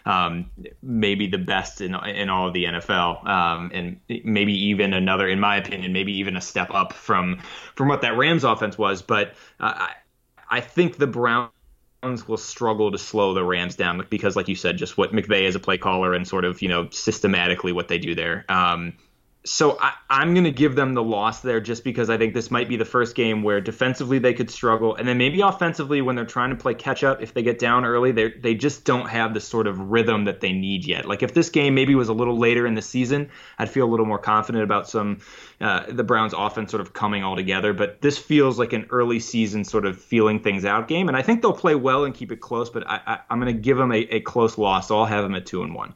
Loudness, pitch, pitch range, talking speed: -22 LUFS, 110 Hz, 100-125 Hz, 245 wpm